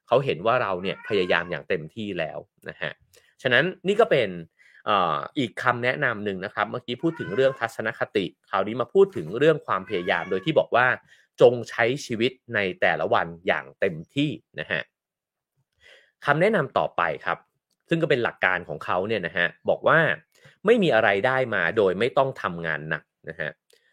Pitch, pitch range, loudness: 125 Hz, 100-155 Hz, -24 LUFS